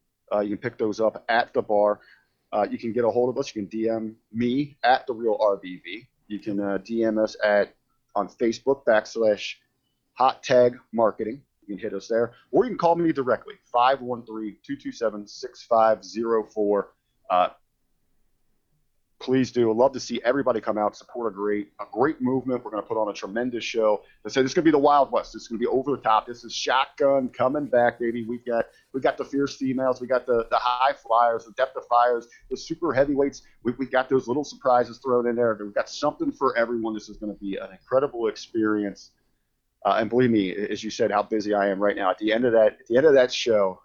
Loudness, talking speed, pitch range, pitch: -24 LUFS, 220 wpm, 105-130 Hz, 115 Hz